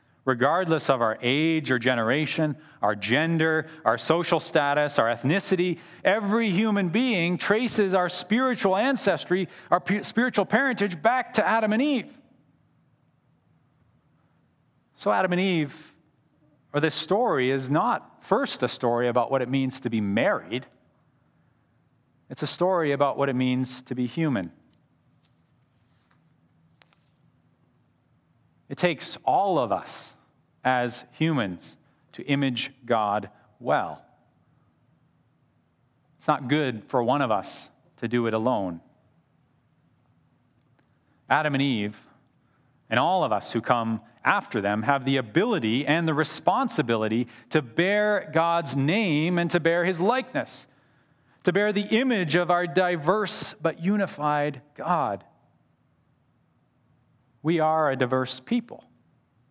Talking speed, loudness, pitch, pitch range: 120 wpm, -25 LUFS, 150 Hz, 130-180 Hz